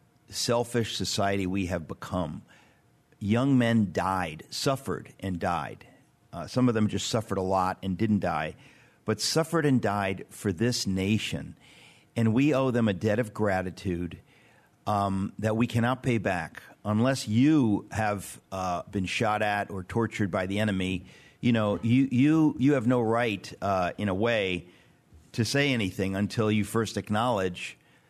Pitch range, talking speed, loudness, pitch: 95-120 Hz, 160 wpm, -28 LUFS, 105 Hz